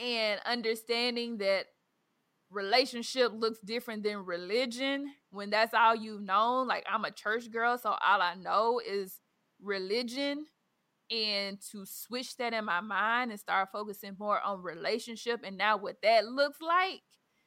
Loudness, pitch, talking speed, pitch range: -31 LUFS, 225 Hz, 150 wpm, 205-245 Hz